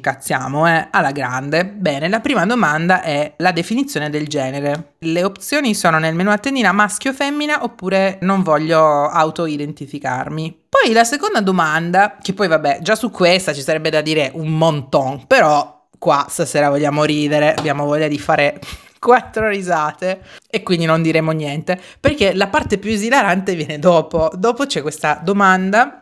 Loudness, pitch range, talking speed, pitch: -16 LUFS, 150-200 Hz, 155 wpm, 165 Hz